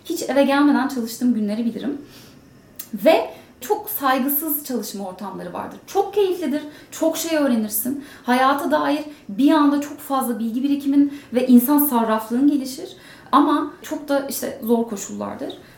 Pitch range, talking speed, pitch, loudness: 245-300 Hz, 135 wpm, 280 Hz, -20 LUFS